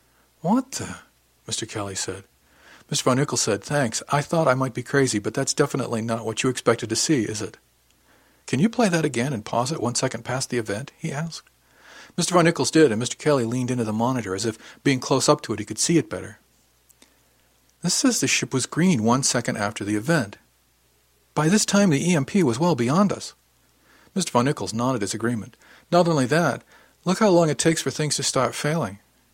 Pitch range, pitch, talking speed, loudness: 110-155 Hz, 130 Hz, 215 wpm, -23 LUFS